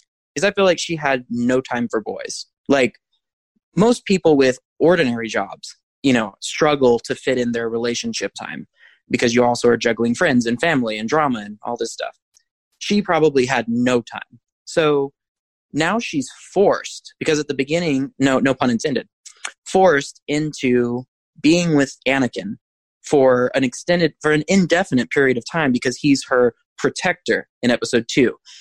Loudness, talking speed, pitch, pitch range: -19 LUFS, 160 wpm, 135 Hz, 120-160 Hz